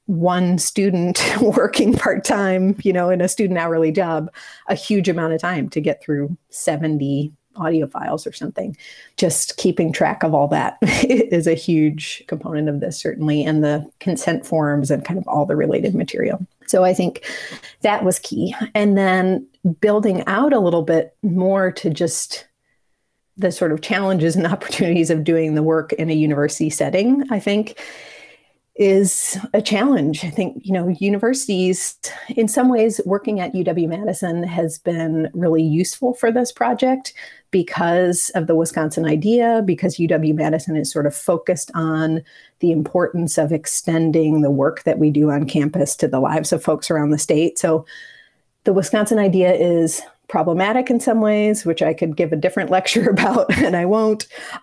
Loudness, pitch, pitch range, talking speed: -18 LUFS, 175 Hz, 160-200 Hz, 170 wpm